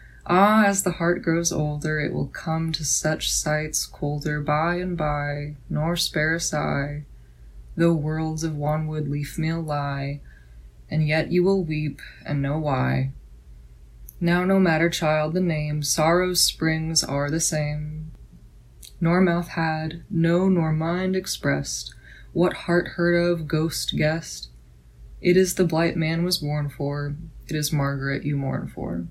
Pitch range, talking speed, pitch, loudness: 145-170 Hz, 150 wpm, 155 Hz, -23 LUFS